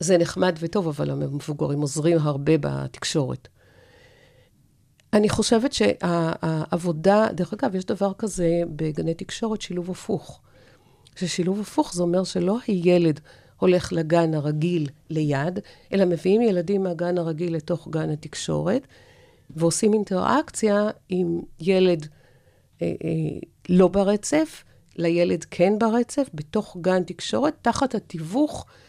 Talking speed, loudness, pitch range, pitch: 110 wpm, -23 LUFS, 155-200 Hz, 175 Hz